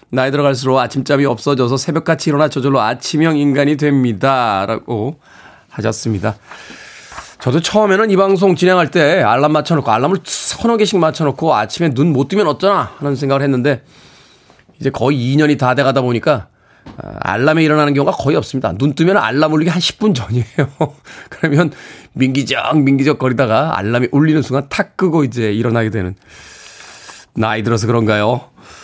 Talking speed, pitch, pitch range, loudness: 360 characters per minute, 140 Hz, 125-160 Hz, -14 LUFS